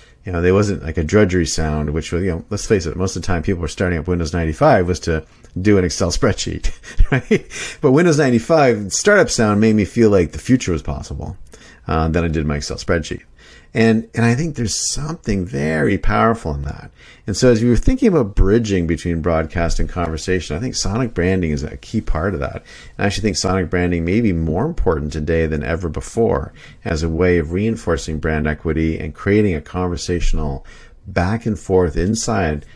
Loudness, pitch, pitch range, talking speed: -18 LUFS, 90 Hz, 80-105 Hz, 205 wpm